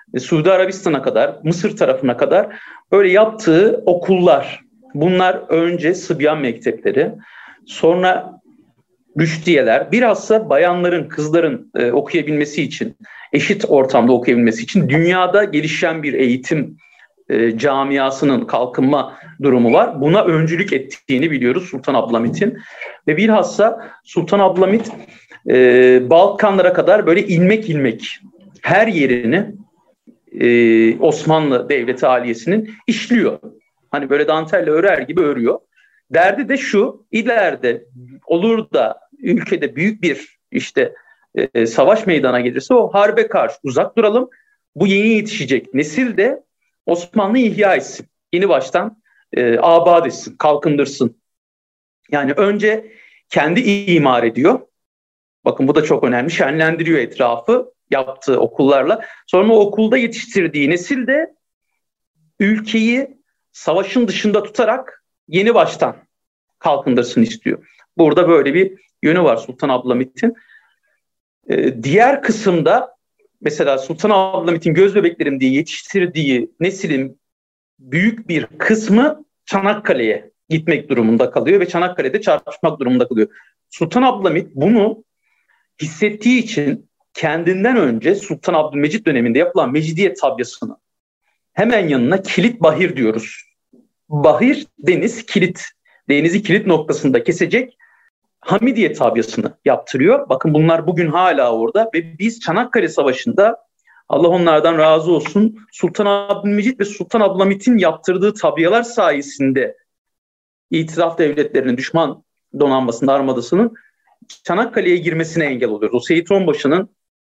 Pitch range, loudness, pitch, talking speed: 150-220 Hz, -15 LUFS, 180 Hz, 110 wpm